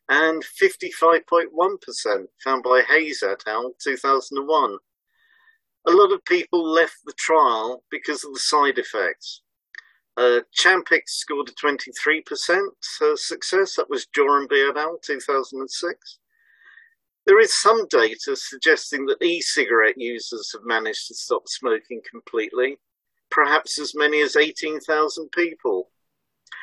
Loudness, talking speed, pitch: -21 LUFS, 115 wpm, 365 Hz